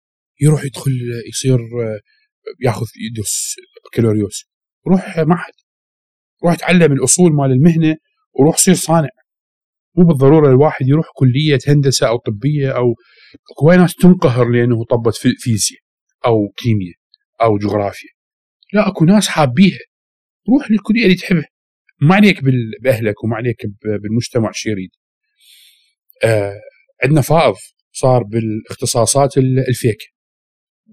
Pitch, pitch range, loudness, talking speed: 135 Hz, 115-180 Hz, -14 LUFS, 115 wpm